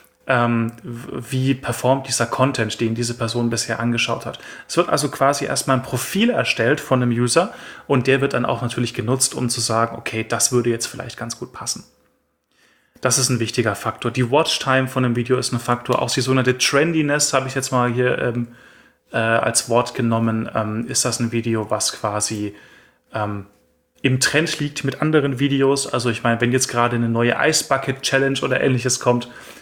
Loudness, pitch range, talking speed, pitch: -19 LUFS, 115-135 Hz, 190 wpm, 125 Hz